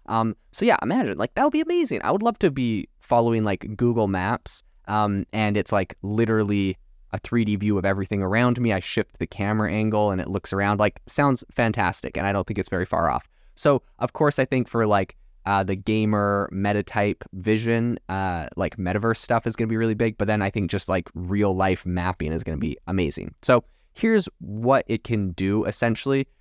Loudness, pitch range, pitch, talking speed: -24 LUFS, 95-115 Hz, 105 Hz, 215 wpm